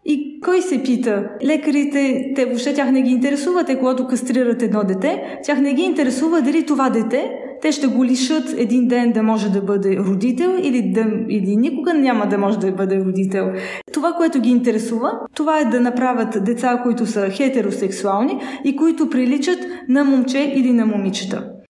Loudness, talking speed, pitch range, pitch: -18 LUFS, 170 wpm, 220-285 Hz, 255 Hz